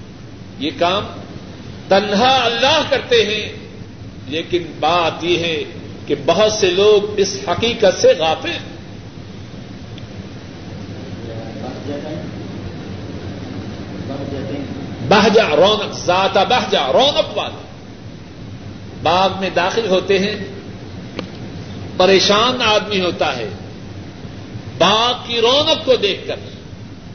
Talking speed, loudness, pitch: 85 wpm, -16 LUFS, 145 Hz